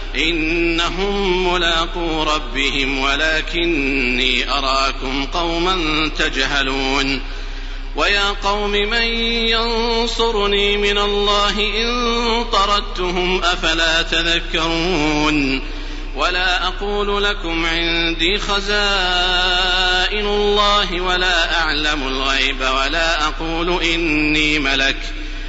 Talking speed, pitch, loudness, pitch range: 70 wpm, 170 Hz, -17 LUFS, 150-200 Hz